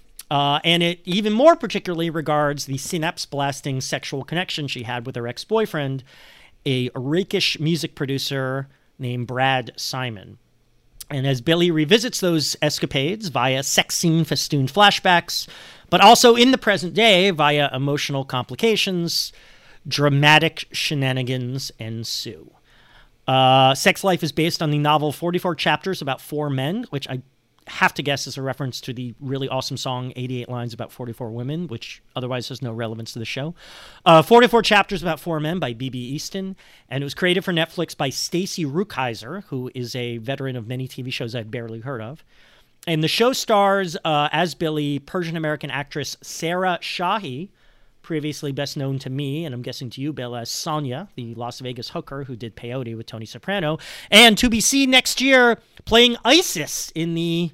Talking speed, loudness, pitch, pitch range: 170 wpm, -20 LUFS, 145 Hz, 130-175 Hz